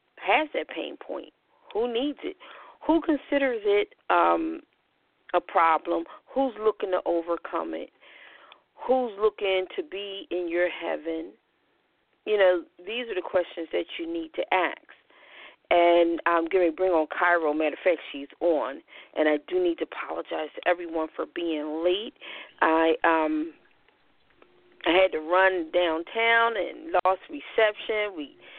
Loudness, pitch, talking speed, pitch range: -26 LUFS, 185 Hz, 145 wpm, 170-265 Hz